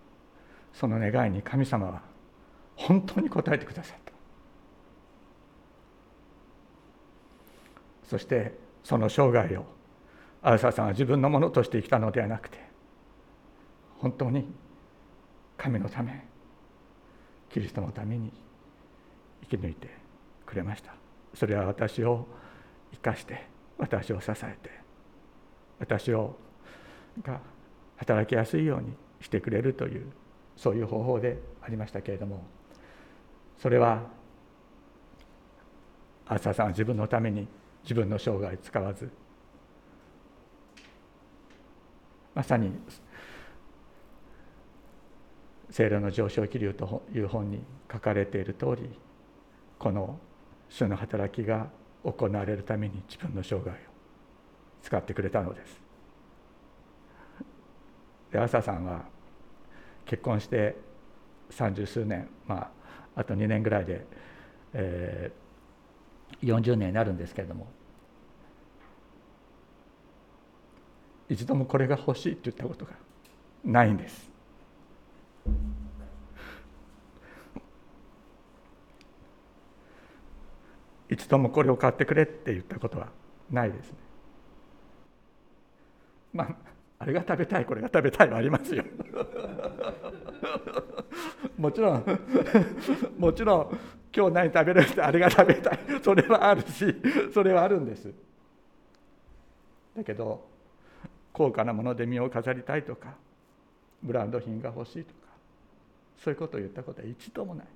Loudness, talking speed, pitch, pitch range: -28 LUFS, 215 characters per minute, 115 Hz, 100-135 Hz